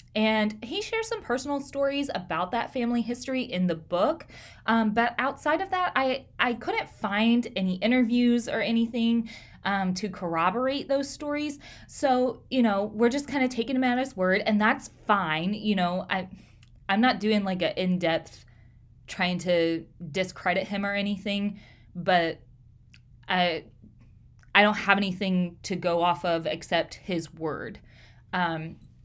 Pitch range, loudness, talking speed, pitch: 170-240 Hz, -27 LUFS, 155 wpm, 200 Hz